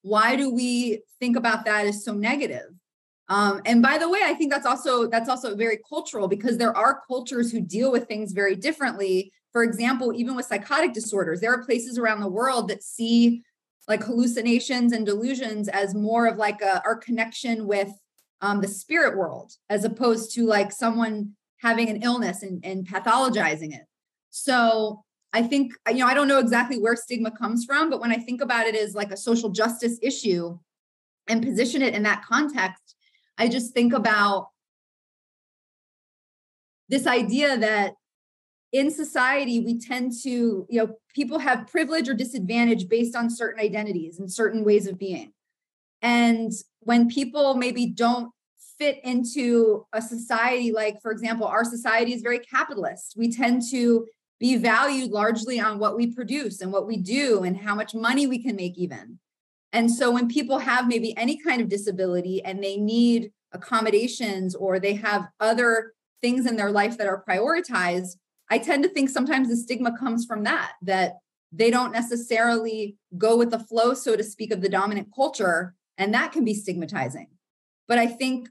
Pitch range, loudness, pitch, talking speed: 210-245 Hz, -24 LUFS, 230 Hz, 175 wpm